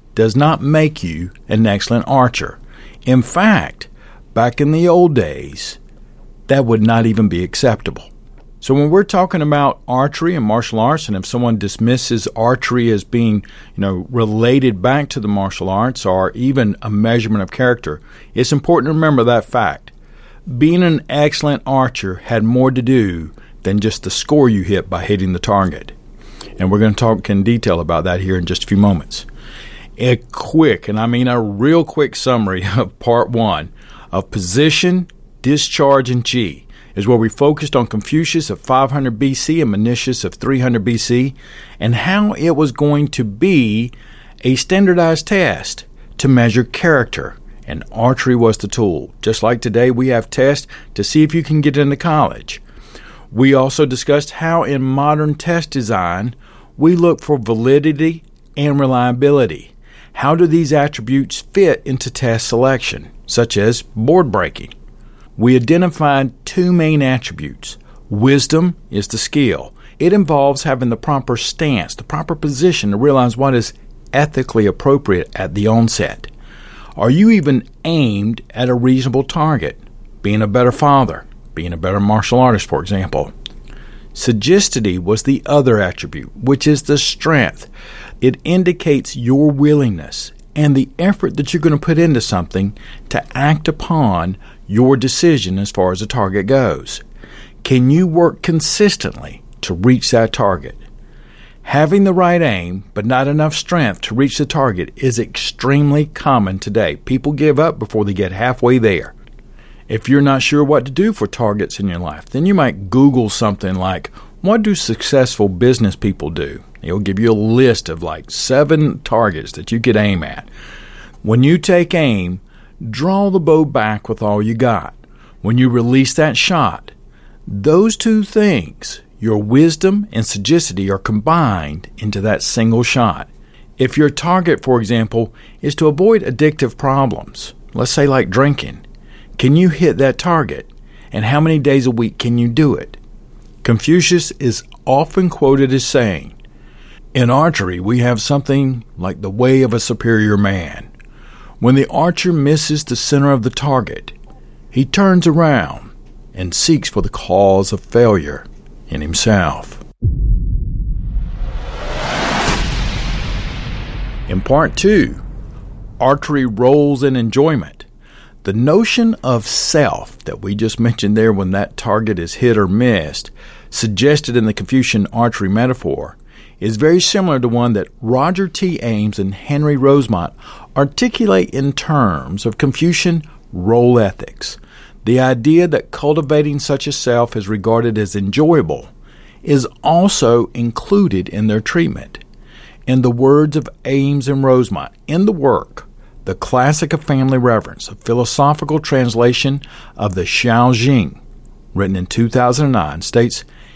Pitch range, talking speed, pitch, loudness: 110-145 Hz, 150 wpm, 125 Hz, -14 LUFS